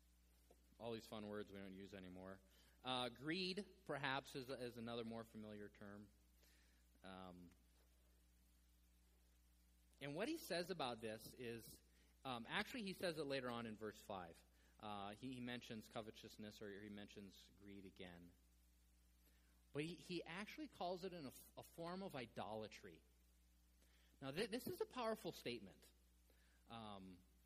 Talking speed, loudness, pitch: 140 wpm, -52 LUFS, 100 Hz